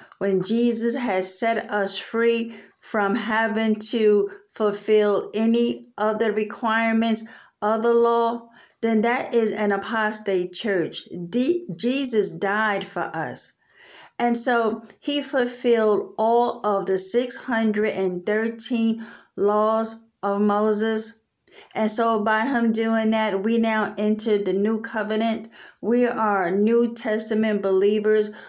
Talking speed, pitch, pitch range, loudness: 115 wpm, 220 Hz, 210-230 Hz, -22 LUFS